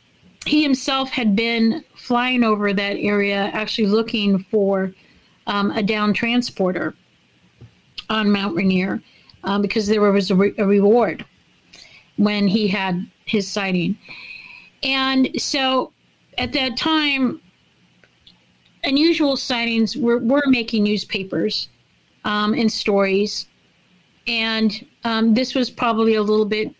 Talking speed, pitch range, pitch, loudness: 120 wpm, 200-245 Hz, 215 Hz, -19 LUFS